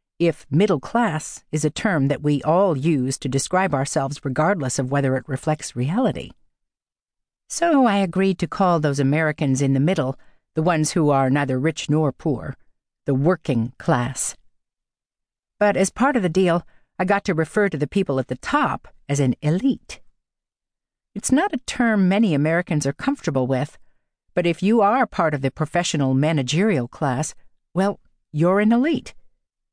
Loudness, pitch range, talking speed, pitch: -21 LUFS, 140-190 Hz, 165 wpm, 155 Hz